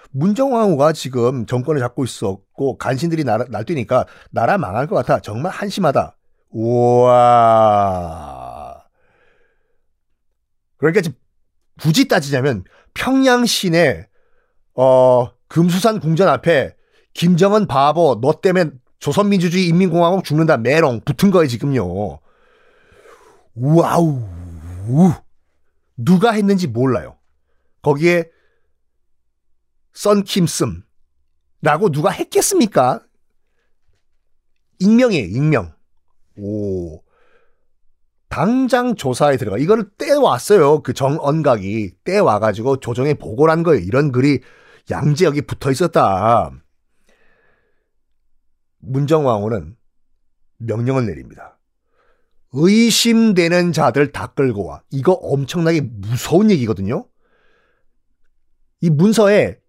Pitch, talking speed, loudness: 135 Hz, 215 characters per minute, -16 LUFS